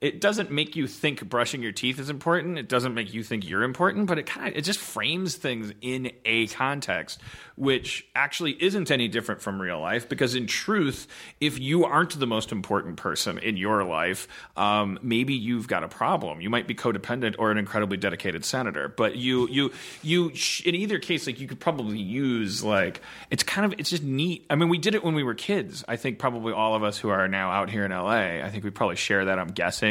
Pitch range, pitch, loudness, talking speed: 110-160 Hz, 125 Hz, -26 LUFS, 230 wpm